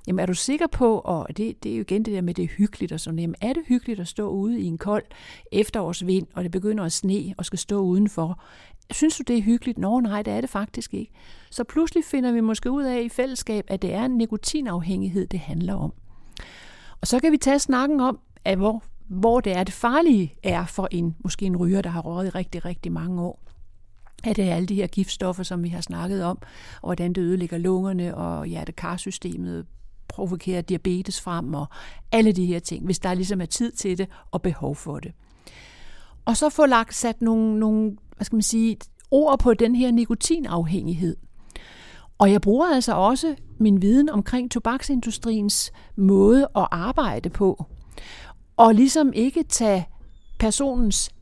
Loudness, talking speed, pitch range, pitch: -23 LUFS, 200 wpm, 180-235 Hz, 195 Hz